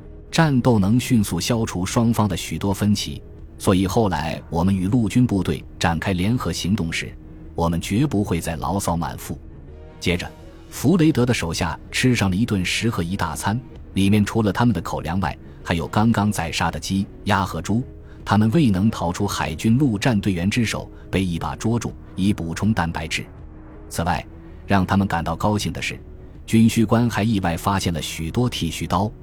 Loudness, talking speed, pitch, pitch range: -21 LUFS, 270 characters per minute, 95 Hz, 80-110 Hz